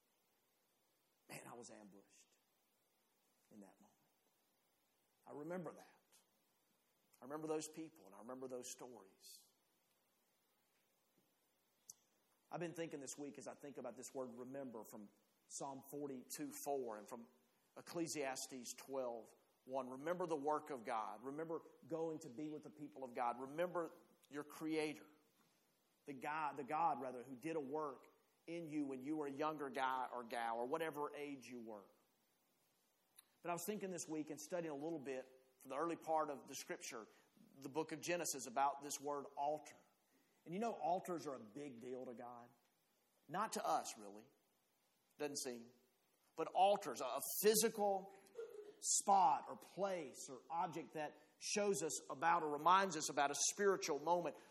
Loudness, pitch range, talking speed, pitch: -44 LUFS, 130-165 Hz, 155 wpm, 145 Hz